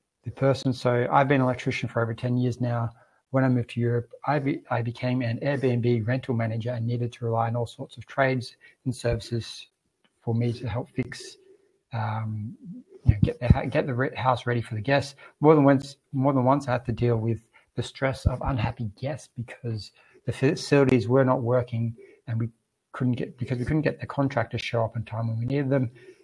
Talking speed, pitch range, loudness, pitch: 215 wpm, 115-135 Hz, -26 LUFS, 125 Hz